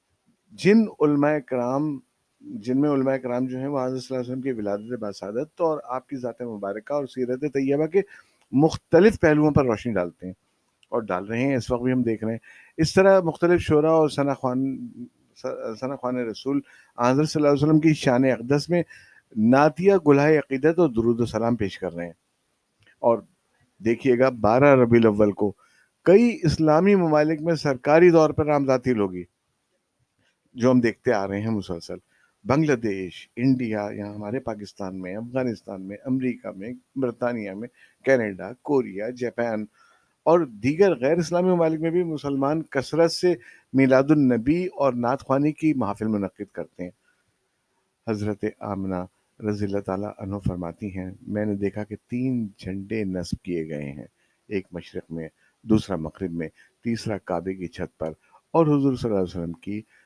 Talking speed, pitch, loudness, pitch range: 170 wpm, 125 Hz, -23 LUFS, 105-150 Hz